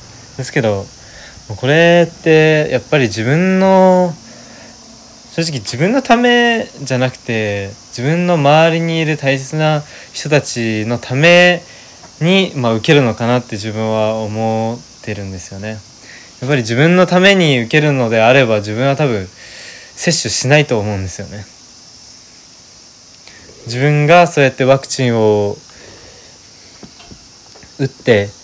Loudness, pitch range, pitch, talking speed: -13 LUFS, 110-160 Hz, 130 Hz, 250 characters per minute